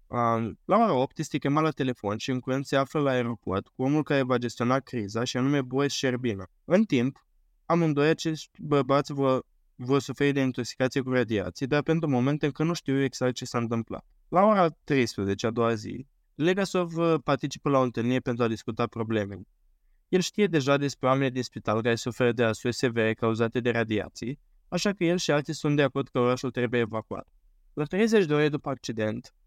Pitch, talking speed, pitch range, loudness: 130 Hz, 190 wpm, 115-145 Hz, -27 LUFS